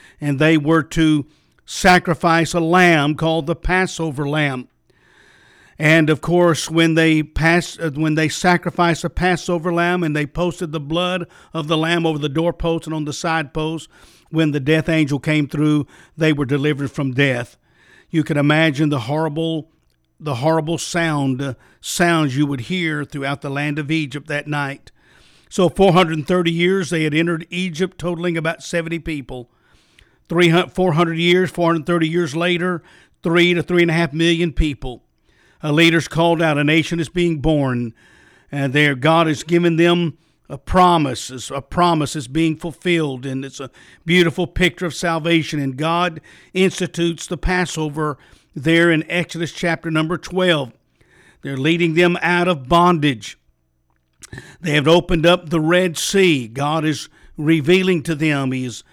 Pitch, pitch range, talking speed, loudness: 160 Hz, 150-175 Hz, 155 wpm, -18 LUFS